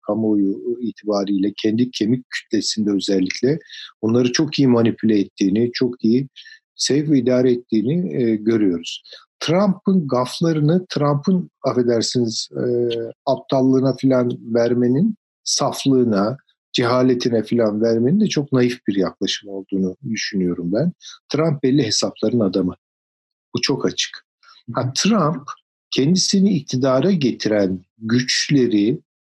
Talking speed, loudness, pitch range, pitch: 105 wpm, -19 LUFS, 110-140 Hz, 125 Hz